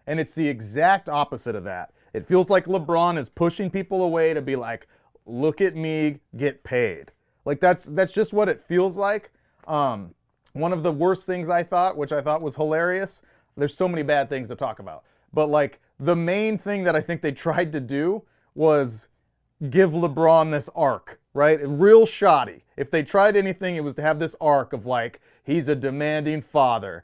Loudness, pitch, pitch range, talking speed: -22 LUFS, 155 Hz, 145-180 Hz, 195 wpm